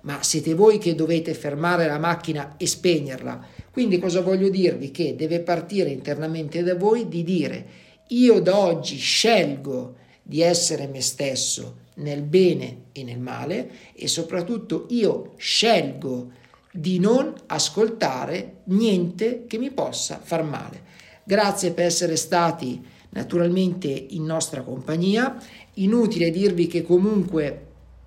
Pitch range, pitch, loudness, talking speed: 145-190 Hz, 170 Hz, -22 LUFS, 130 wpm